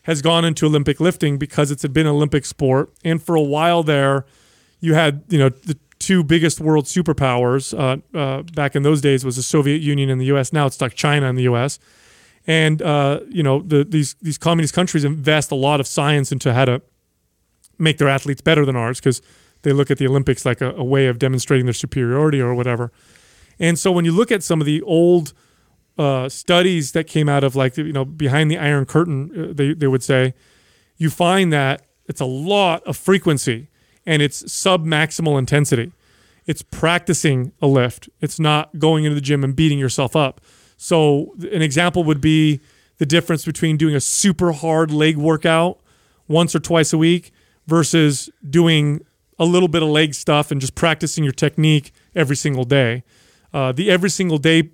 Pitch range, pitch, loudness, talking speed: 135-160 Hz, 150 Hz, -17 LUFS, 195 wpm